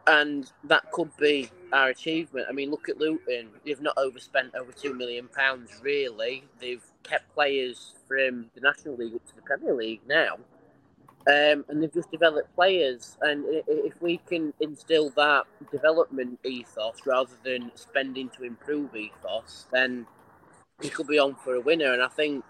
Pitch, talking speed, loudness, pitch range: 140 Hz, 170 wpm, -27 LUFS, 125-155 Hz